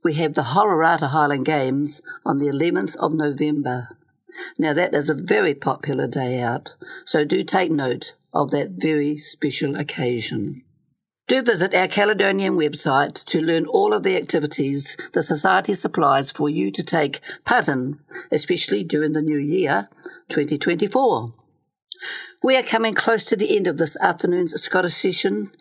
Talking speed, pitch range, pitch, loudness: 155 wpm, 145-195 Hz, 155 Hz, -21 LUFS